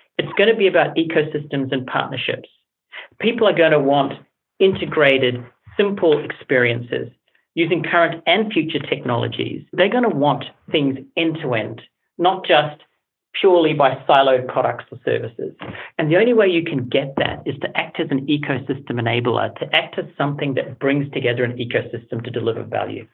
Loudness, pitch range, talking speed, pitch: -19 LUFS, 130-170 Hz, 165 wpm, 150 Hz